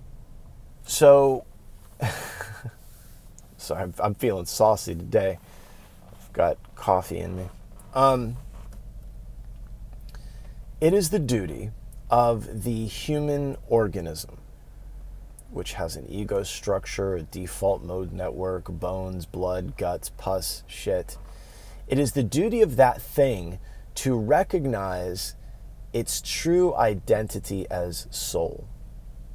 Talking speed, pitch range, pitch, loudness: 100 wpm, 90-125 Hz, 110 Hz, -25 LUFS